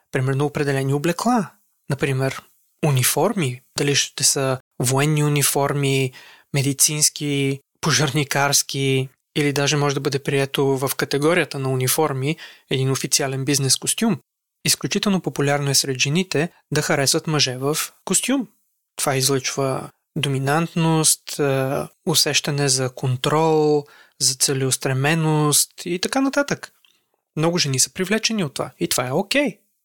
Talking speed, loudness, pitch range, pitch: 115 wpm, -20 LUFS, 135-160 Hz, 145 Hz